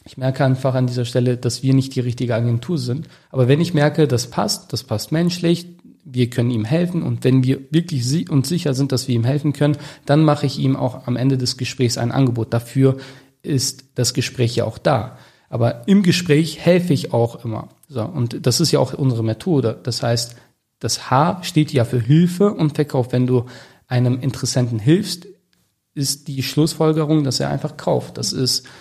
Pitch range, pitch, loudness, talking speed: 125-150 Hz, 135 Hz, -19 LUFS, 200 wpm